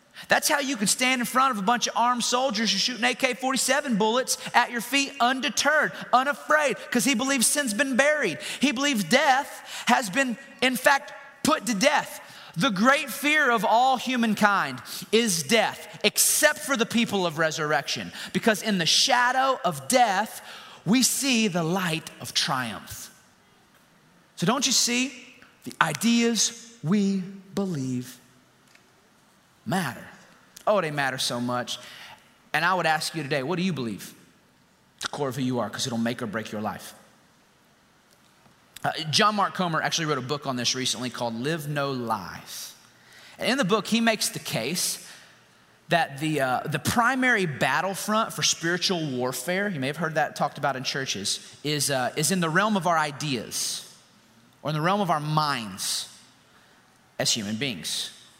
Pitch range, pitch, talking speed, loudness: 150-250 Hz, 200 Hz, 165 wpm, -24 LUFS